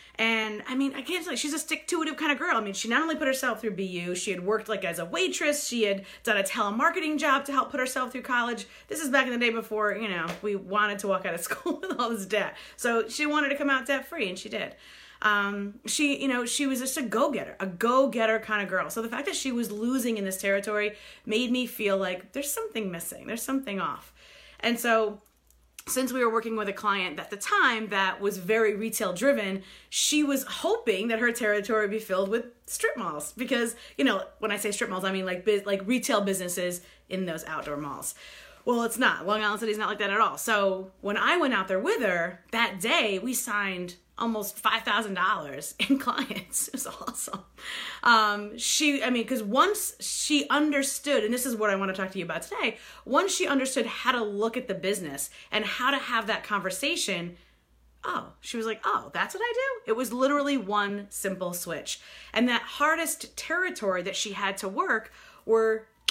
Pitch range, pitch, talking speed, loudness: 200-265 Hz, 225 Hz, 220 wpm, -27 LUFS